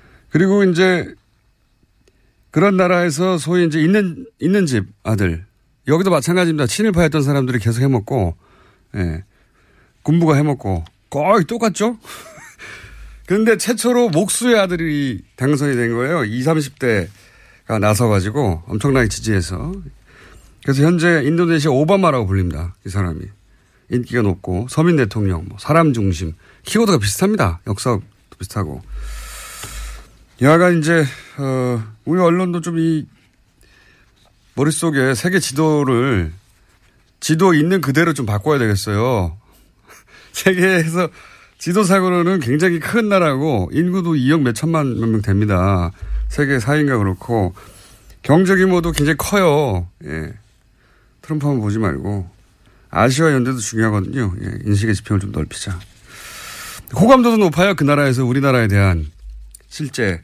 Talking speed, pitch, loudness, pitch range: 280 characters per minute, 130 Hz, -17 LUFS, 100-165 Hz